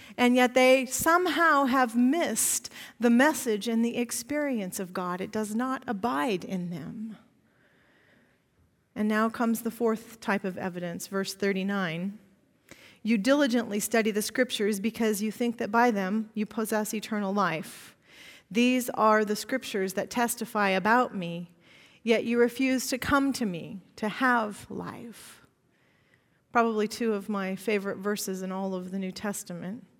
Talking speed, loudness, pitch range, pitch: 150 wpm, -27 LUFS, 200-240 Hz, 220 Hz